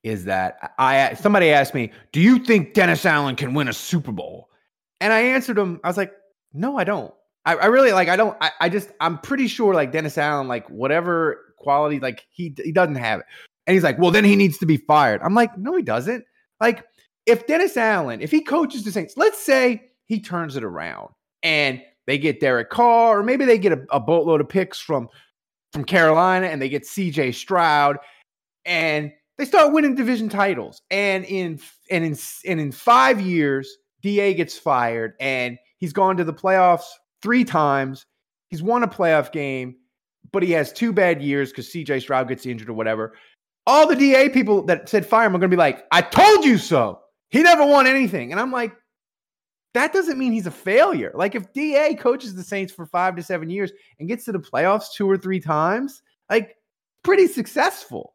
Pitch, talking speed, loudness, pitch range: 185 Hz, 205 wpm, -19 LUFS, 150-230 Hz